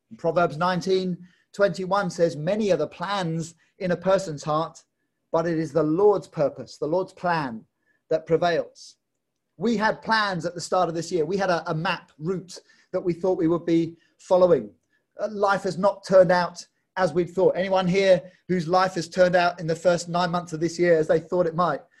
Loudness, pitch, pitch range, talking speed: -24 LUFS, 180 Hz, 170-190 Hz, 200 wpm